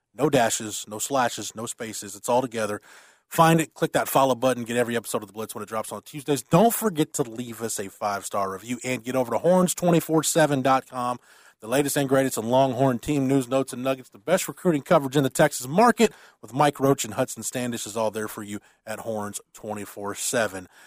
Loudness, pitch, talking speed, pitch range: -24 LUFS, 130 Hz, 205 wpm, 110-145 Hz